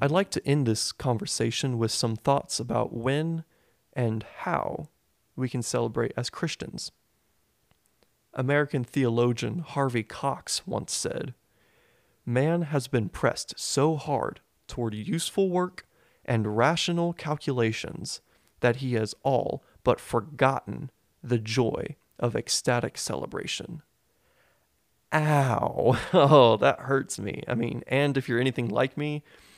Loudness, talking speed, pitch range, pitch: -27 LUFS, 120 wpm, 120-150 Hz, 130 Hz